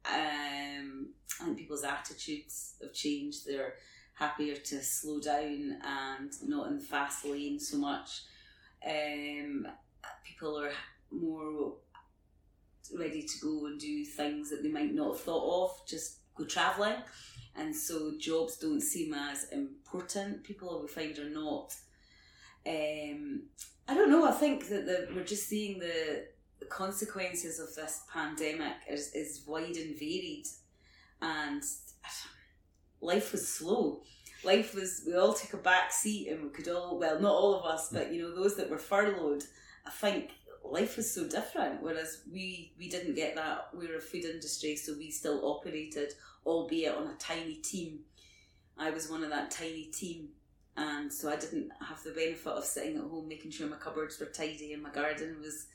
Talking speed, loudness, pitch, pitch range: 170 wpm, -36 LUFS, 160 Hz, 150-195 Hz